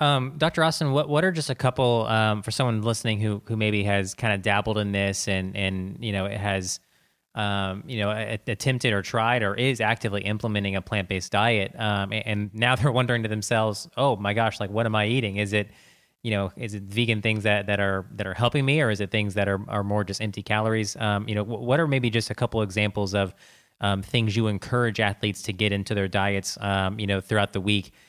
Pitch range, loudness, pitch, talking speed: 100-115 Hz, -25 LUFS, 105 Hz, 240 wpm